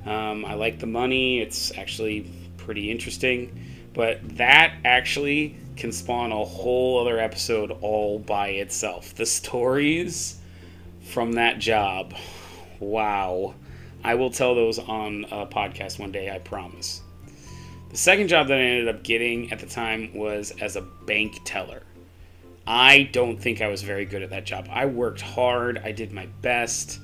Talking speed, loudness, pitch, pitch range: 160 wpm, -23 LUFS, 105 Hz, 90-120 Hz